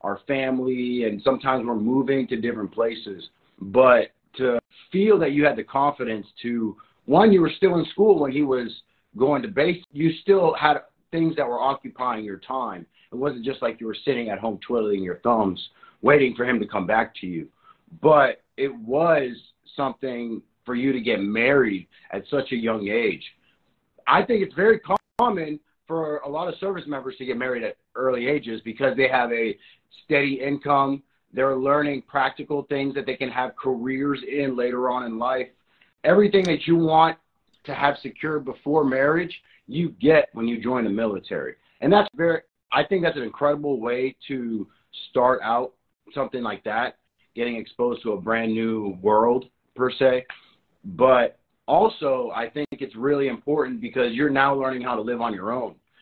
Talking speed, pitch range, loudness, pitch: 180 wpm, 120-150 Hz, -23 LUFS, 135 Hz